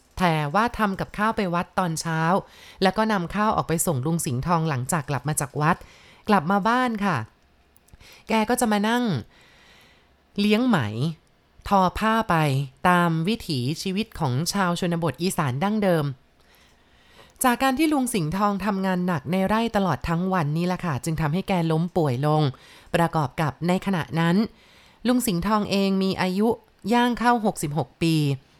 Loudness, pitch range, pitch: -23 LUFS, 155-205 Hz, 180 Hz